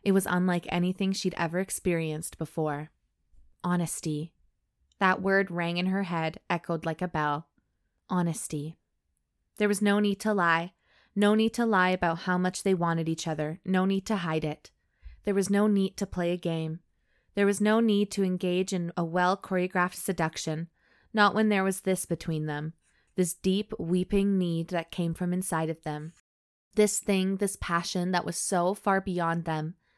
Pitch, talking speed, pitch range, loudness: 180 Hz, 175 wpm, 160-195 Hz, -28 LUFS